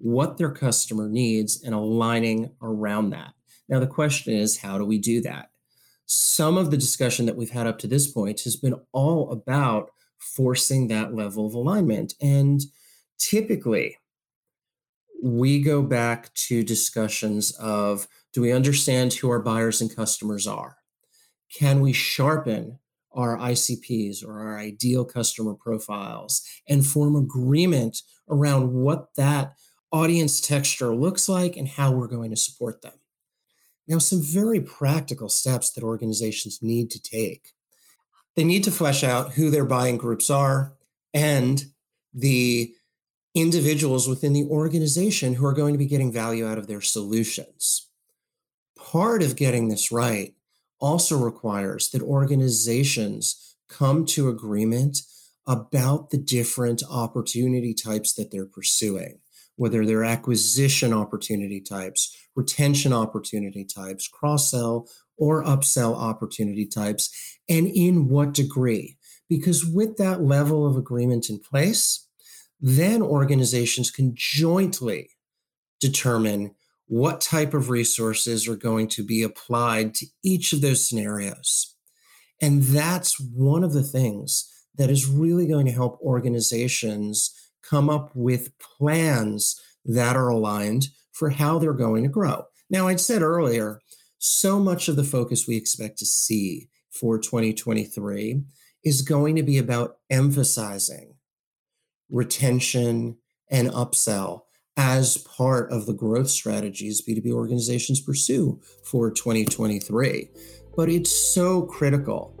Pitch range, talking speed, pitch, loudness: 115-145 Hz, 130 wpm, 125 Hz, -23 LUFS